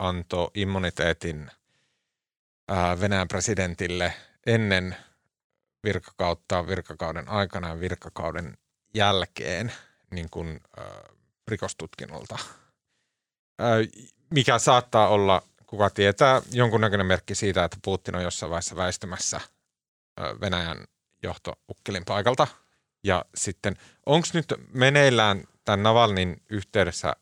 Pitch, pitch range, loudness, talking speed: 95 Hz, 90-110 Hz, -25 LUFS, 85 wpm